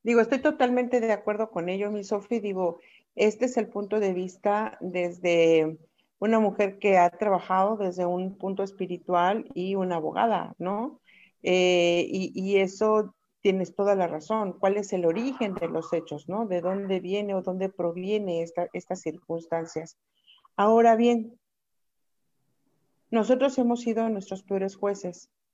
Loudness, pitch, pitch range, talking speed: -26 LUFS, 195 Hz, 180-215 Hz, 150 wpm